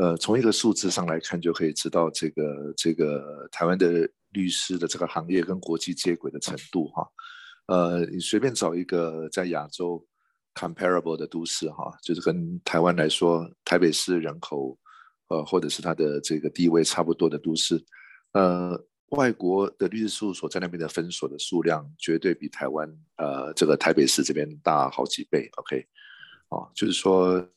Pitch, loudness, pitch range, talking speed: 85 Hz, -26 LUFS, 80-90 Hz, 290 characters per minute